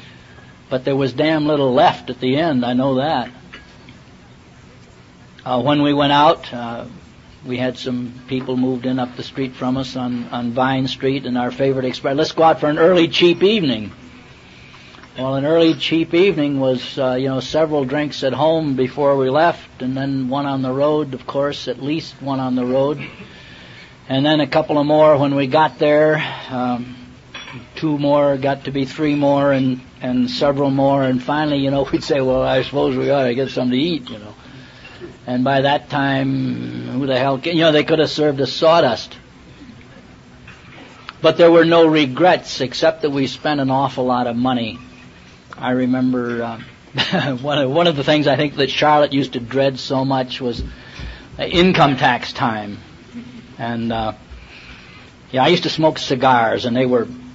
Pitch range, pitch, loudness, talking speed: 125-145 Hz, 135 Hz, -17 LUFS, 185 wpm